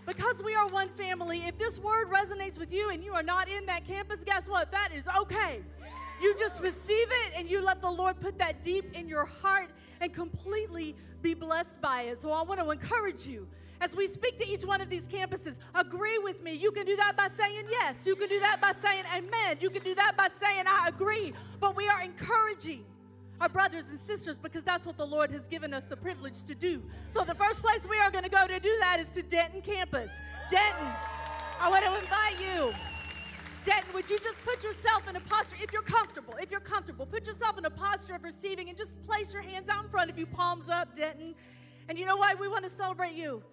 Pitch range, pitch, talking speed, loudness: 350-415 Hz, 390 Hz, 230 wpm, -31 LUFS